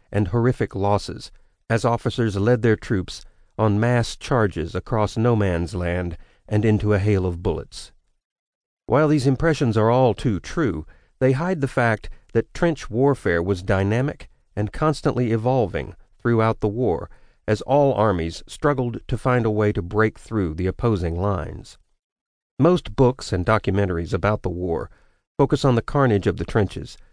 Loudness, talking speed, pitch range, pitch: -22 LUFS, 155 wpm, 100-125 Hz, 110 Hz